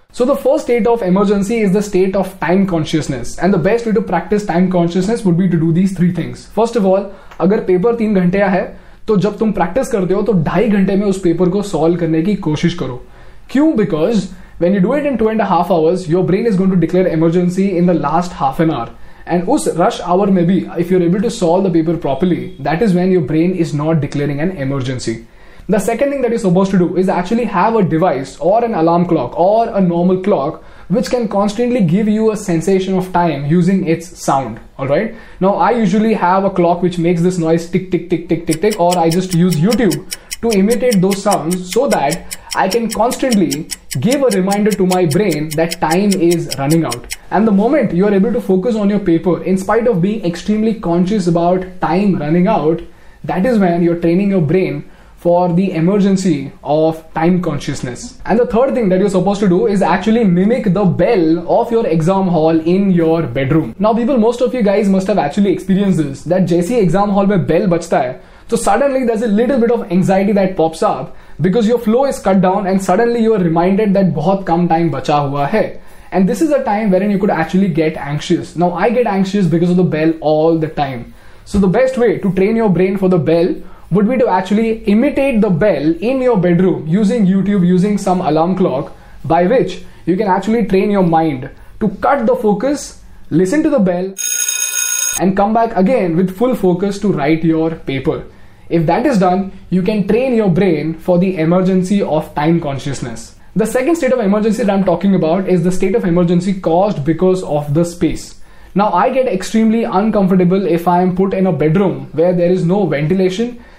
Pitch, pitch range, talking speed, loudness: 185 Hz, 170-210 Hz, 215 wpm, -14 LUFS